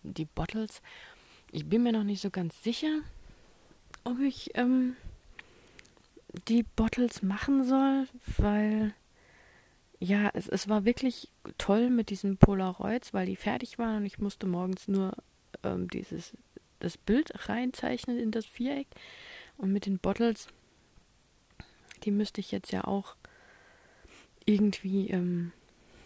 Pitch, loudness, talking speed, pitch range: 210 Hz, -31 LUFS, 130 wpm, 195-245 Hz